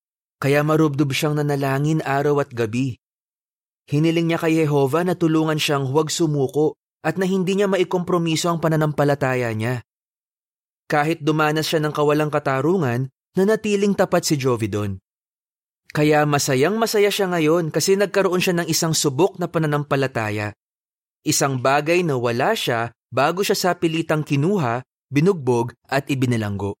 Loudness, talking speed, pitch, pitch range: -20 LUFS, 135 wpm, 155 Hz, 135-170 Hz